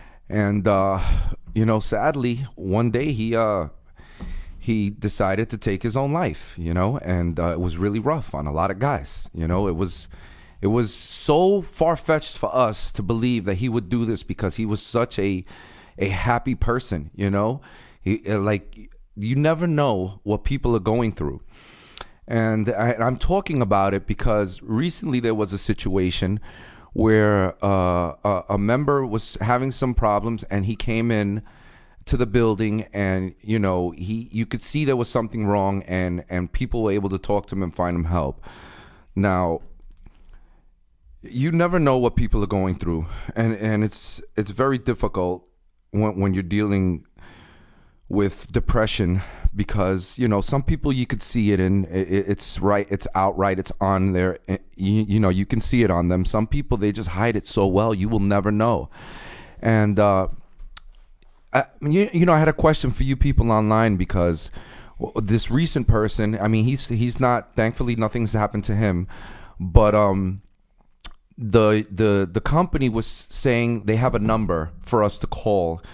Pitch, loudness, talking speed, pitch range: 105 Hz, -22 LUFS, 175 wpm, 95-115 Hz